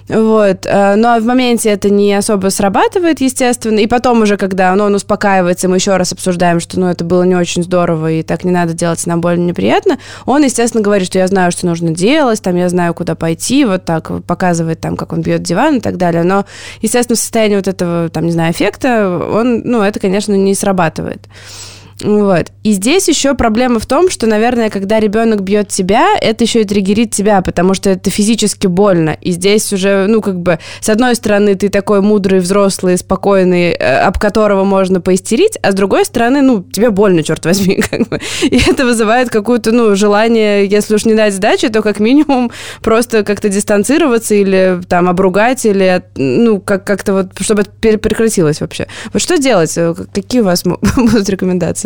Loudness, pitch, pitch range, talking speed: -11 LUFS, 200 Hz, 180-225 Hz, 195 wpm